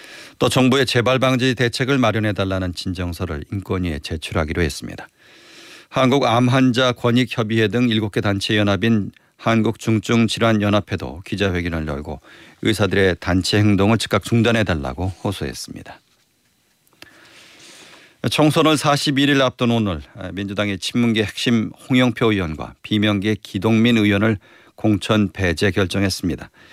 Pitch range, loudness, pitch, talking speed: 95-120 Hz, -19 LUFS, 105 Hz, 305 characters per minute